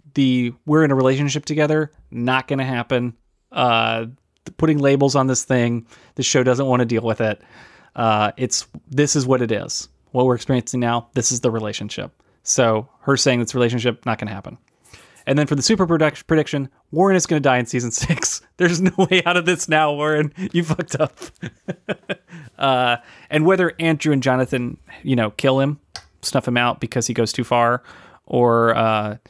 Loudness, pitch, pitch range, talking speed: -19 LUFS, 130 Hz, 120-150 Hz, 185 wpm